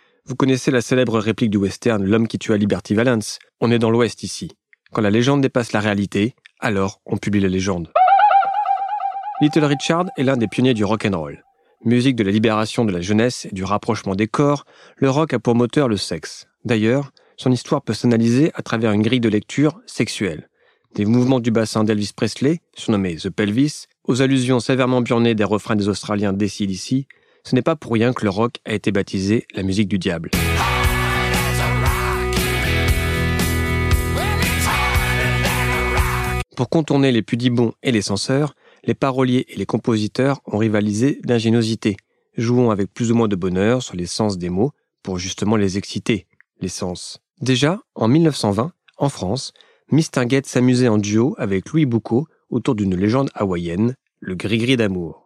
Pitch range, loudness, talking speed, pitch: 100-130 Hz, -19 LUFS, 165 wpm, 115 Hz